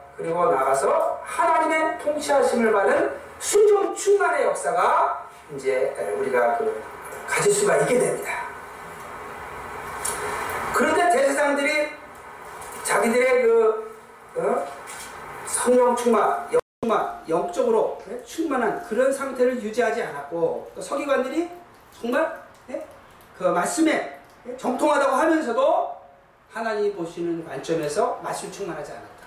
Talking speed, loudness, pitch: 240 characters per minute, -22 LUFS, 320 Hz